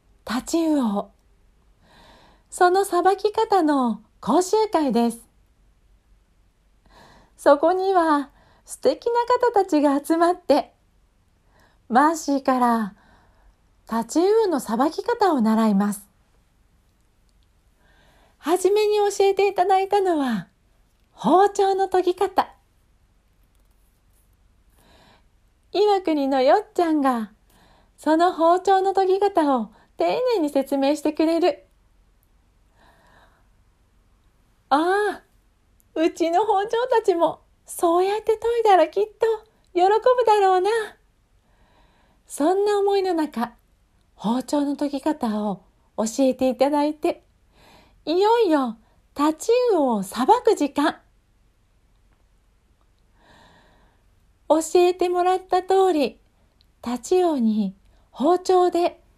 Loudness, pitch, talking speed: -21 LUFS, 305 Hz, 180 characters per minute